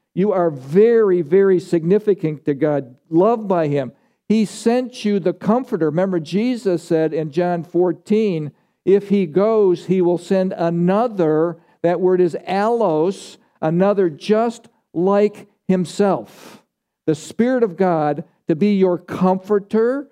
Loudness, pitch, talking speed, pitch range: -18 LUFS, 185 Hz, 130 wpm, 170-205 Hz